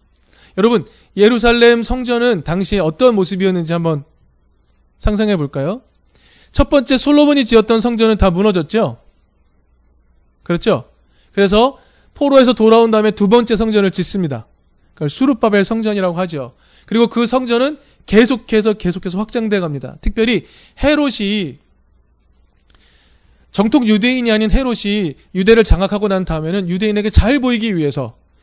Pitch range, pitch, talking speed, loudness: 150-230 Hz, 205 Hz, 310 characters per minute, -14 LUFS